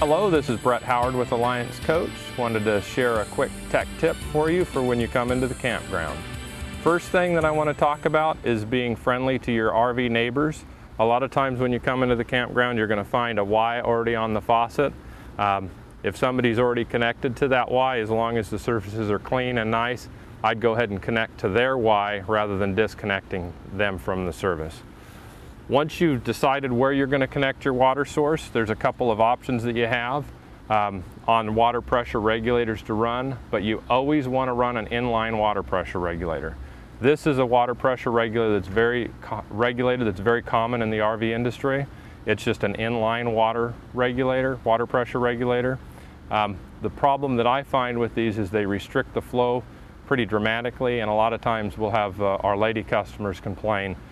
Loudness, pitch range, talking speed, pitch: -24 LUFS, 110-125 Hz, 200 wpm, 120 Hz